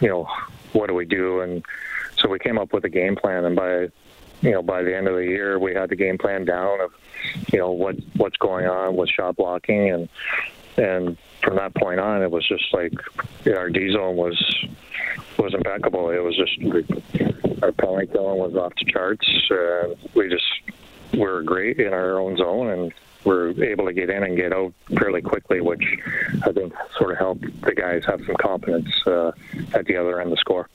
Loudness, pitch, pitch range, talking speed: -22 LUFS, 90 Hz, 90-95 Hz, 210 wpm